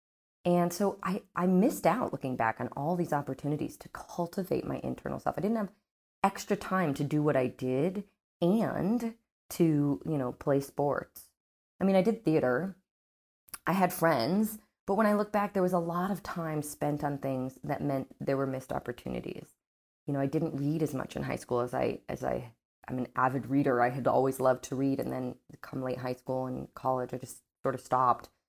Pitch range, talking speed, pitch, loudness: 130-180 Hz, 205 wpm, 145 Hz, -31 LUFS